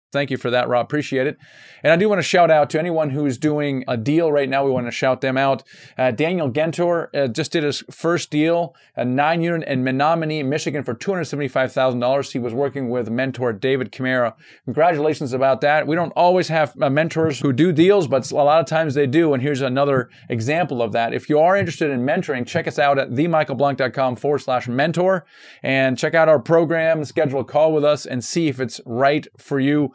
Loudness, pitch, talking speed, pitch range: -19 LUFS, 145 Hz, 215 wpm, 130-160 Hz